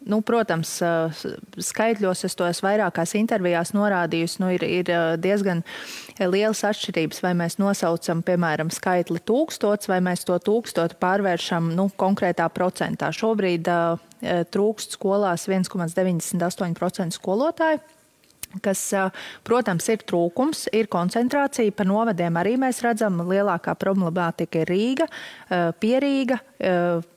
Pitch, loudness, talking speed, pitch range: 190 Hz, -23 LUFS, 115 wpm, 175-215 Hz